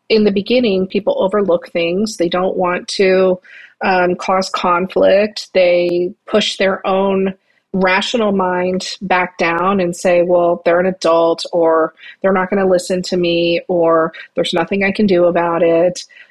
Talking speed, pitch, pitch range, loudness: 160 wpm, 185 Hz, 175-195 Hz, -15 LUFS